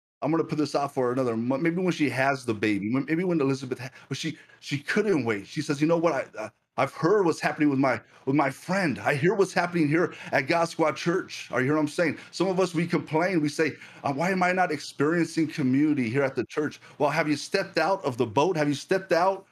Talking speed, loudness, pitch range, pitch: 255 wpm, -26 LUFS, 140-170 Hz, 155 Hz